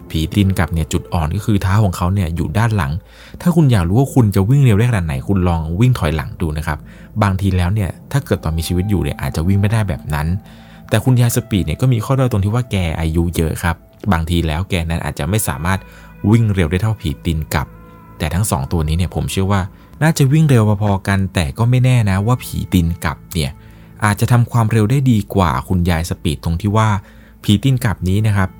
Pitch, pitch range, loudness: 100 Hz, 85-110 Hz, -17 LUFS